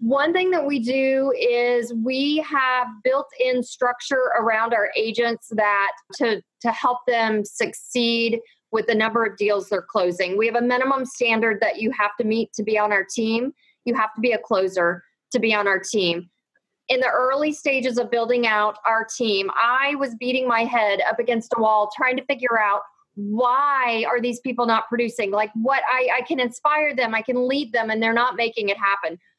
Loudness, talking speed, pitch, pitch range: -21 LUFS, 200 wpm, 235 Hz, 220-255 Hz